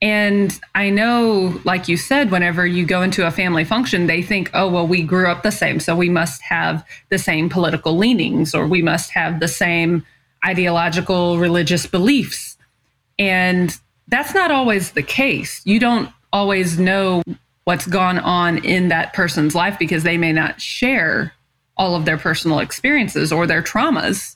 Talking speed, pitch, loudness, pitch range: 170 wpm, 180 Hz, -17 LUFS, 170-195 Hz